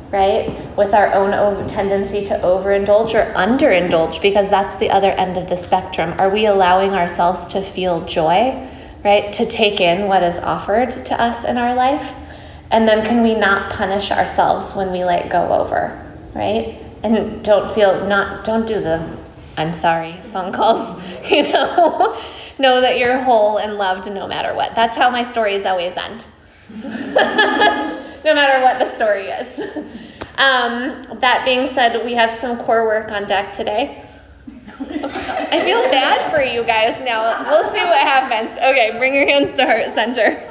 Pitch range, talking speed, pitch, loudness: 195-250 Hz, 165 wpm, 215 Hz, -16 LUFS